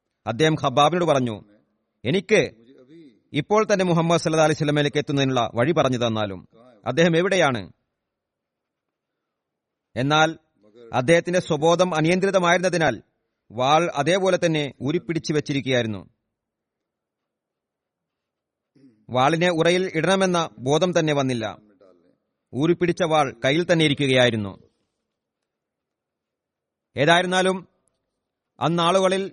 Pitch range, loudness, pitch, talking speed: 125-170 Hz, -21 LUFS, 155 Hz, 80 wpm